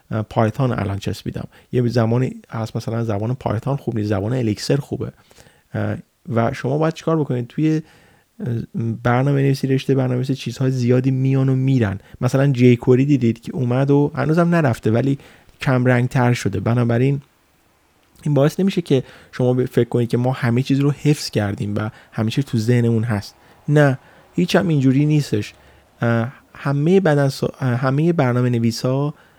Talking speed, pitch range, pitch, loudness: 150 wpm, 115-140 Hz, 125 Hz, -19 LUFS